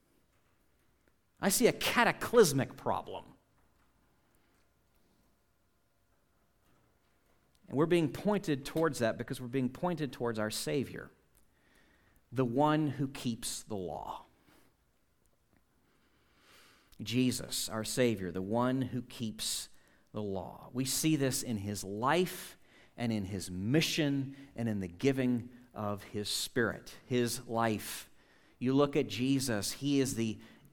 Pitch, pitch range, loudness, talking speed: 125 Hz, 110-140 Hz, -33 LUFS, 115 wpm